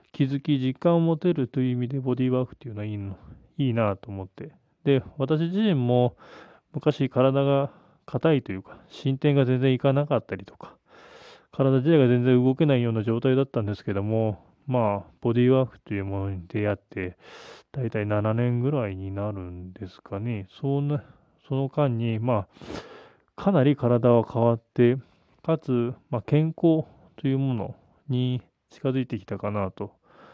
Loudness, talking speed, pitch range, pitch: -25 LUFS, 315 characters per minute, 105-135 Hz, 125 Hz